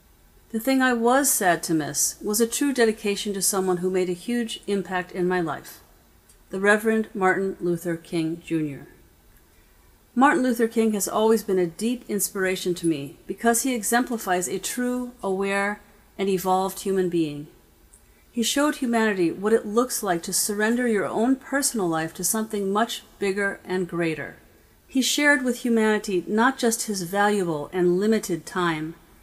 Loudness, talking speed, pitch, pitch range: -23 LUFS, 160 wpm, 200 Hz, 180-230 Hz